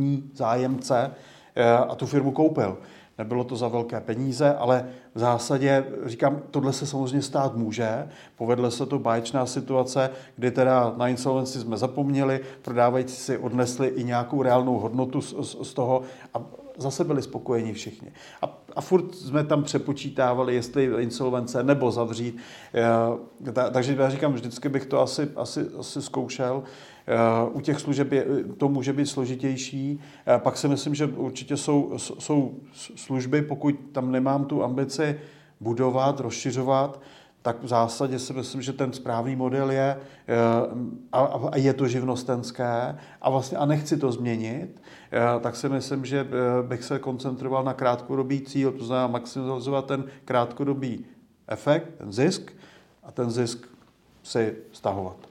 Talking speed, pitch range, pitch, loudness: 145 wpm, 125-140 Hz, 130 Hz, -26 LUFS